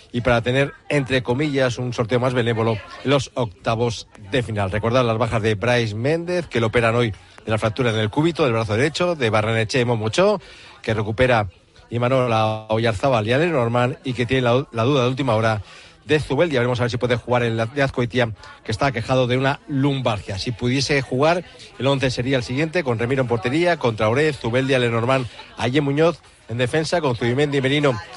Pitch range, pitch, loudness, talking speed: 115-140 Hz, 125 Hz, -20 LUFS, 200 wpm